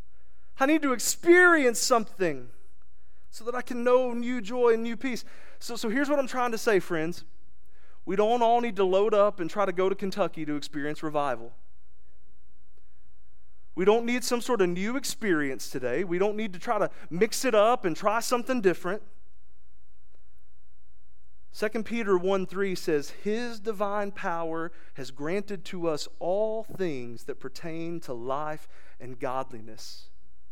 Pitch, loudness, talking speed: 175 Hz, -27 LUFS, 160 wpm